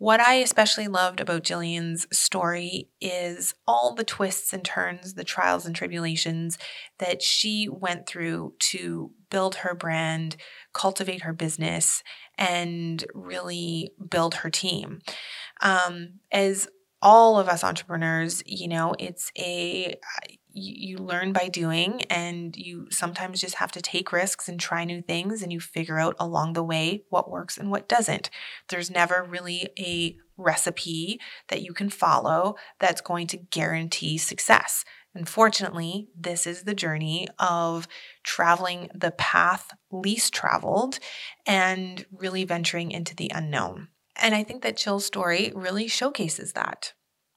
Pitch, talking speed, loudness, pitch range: 180 Hz, 140 wpm, -25 LUFS, 170-195 Hz